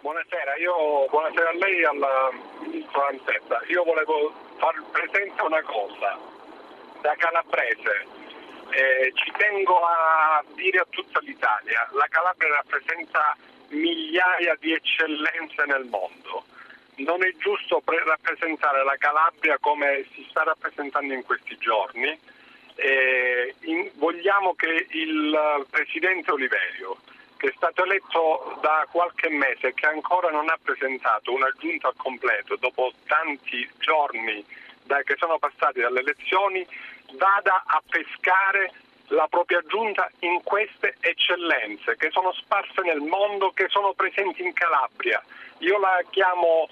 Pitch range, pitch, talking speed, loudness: 150-195 Hz, 170 Hz, 130 wpm, -23 LUFS